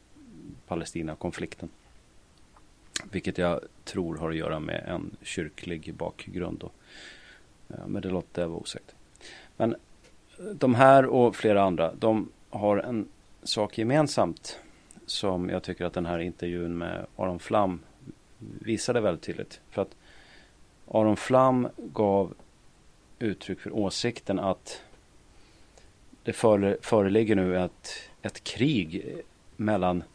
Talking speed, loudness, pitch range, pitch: 115 wpm, -28 LUFS, 90-110 Hz, 100 Hz